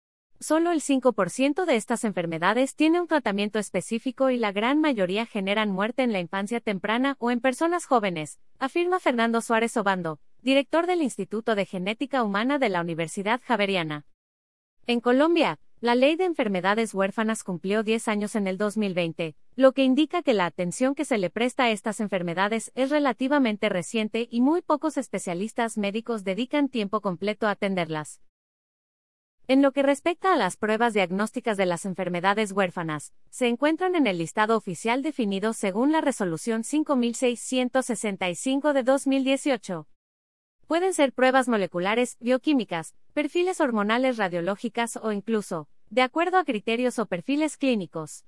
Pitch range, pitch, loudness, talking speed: 195-270 Hz, 230 Hz, -25 LUFS, 150 wpm